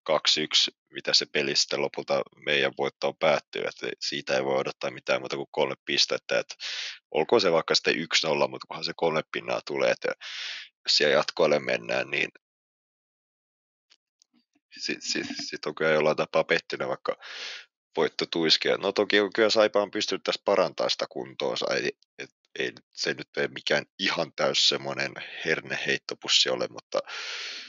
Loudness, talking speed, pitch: -26 LUFS, 165 wpm, 355 Hz